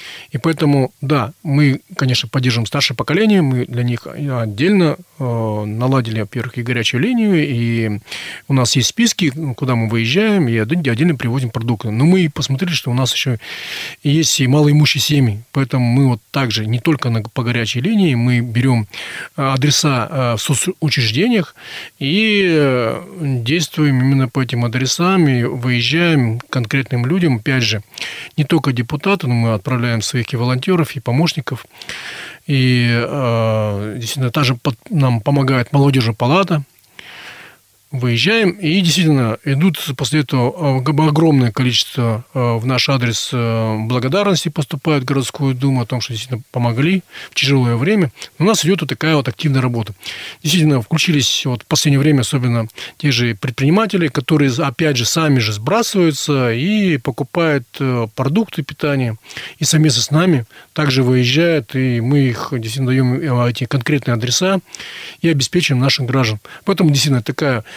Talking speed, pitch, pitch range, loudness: 145 wpm, 135 Hz, 120-155 Hz, -16 LUFS